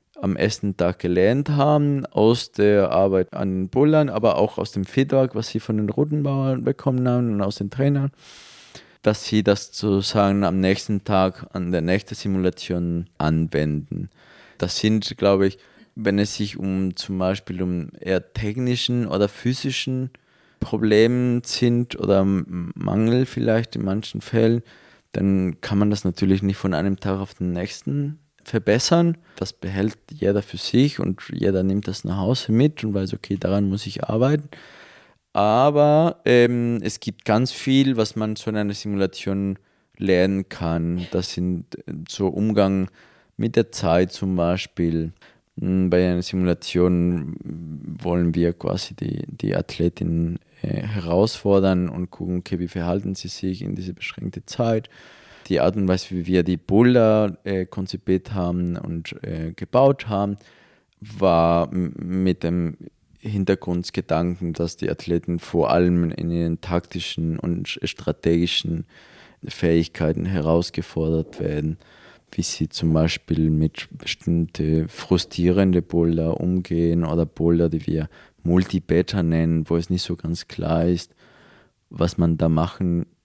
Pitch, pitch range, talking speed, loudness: 95 Hz, 85-110 Hz, 145 wpm, -22 LUFS